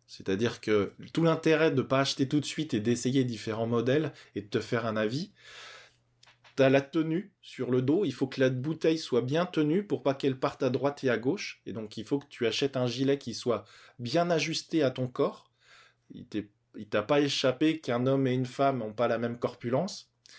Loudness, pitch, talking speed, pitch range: -29 LUFS, 135 Hz, 225 wpm, 120-145 Hz